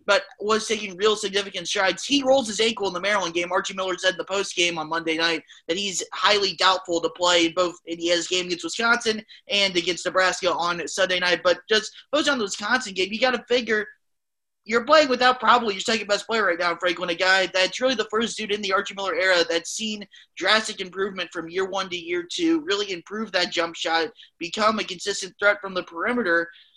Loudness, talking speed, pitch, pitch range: -23 LUFS, 215 wpm, 195 Hz, 180-220 Hz